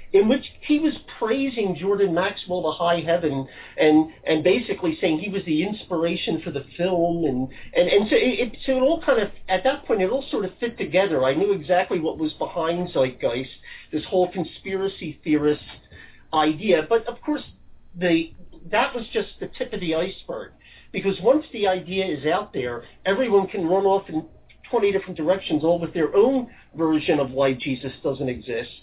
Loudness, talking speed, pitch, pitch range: -23 LUFS, 185 wpm, 180 Hz, 155-200 Hz